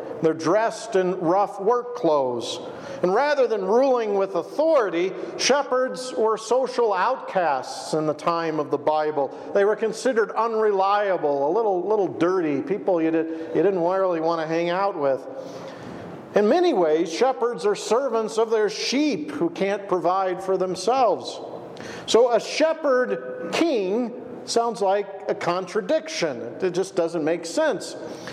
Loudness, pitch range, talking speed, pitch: -23 LUFS, 170-245 Hz, 145 wpm, 200 Hz